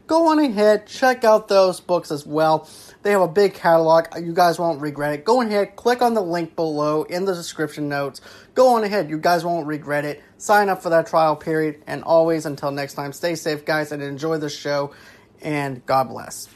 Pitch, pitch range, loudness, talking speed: 165 Hz, 150-195 Hz, -20 LUFS, 215 wpm